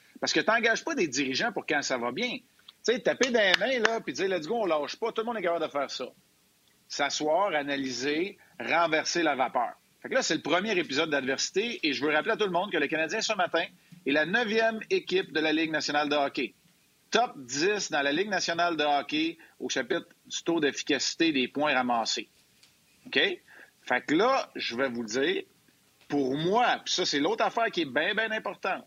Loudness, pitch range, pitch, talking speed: -28 LUFS, 145-225 Hz, 170 Hz, 220 wpm